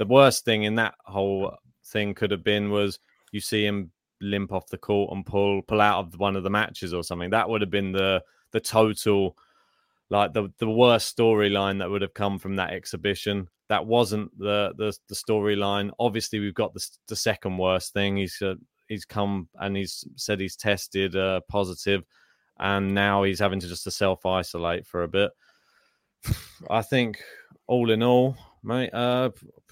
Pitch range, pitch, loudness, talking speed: 95-110 Hz, 100 Hz, -25 LUFS, 185 wpm